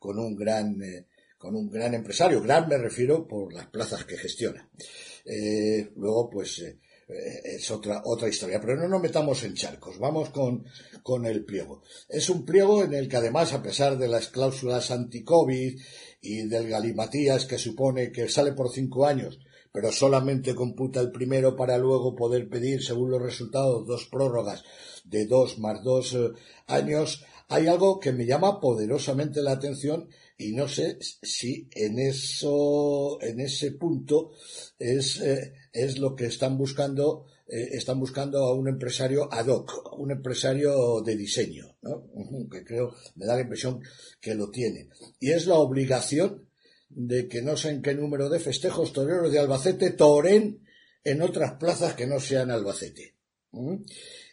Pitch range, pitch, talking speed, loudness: 120-145 Hz, 130 Hz, 165 wpm, -27 LUFS